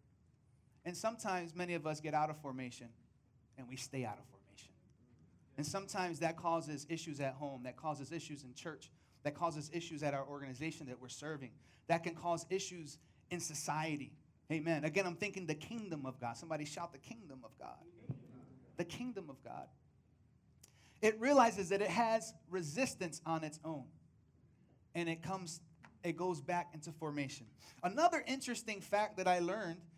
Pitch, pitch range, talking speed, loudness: 160 Hz, 140-180 Hz, 165 wpm, -40 LUFS